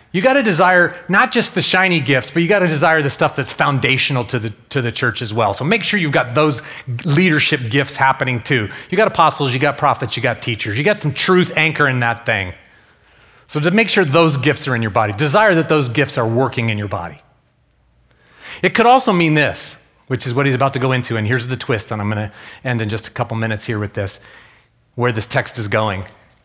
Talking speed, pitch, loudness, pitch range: 230 wpm, 135 Hz, -16 LUFS, 115-160 Hz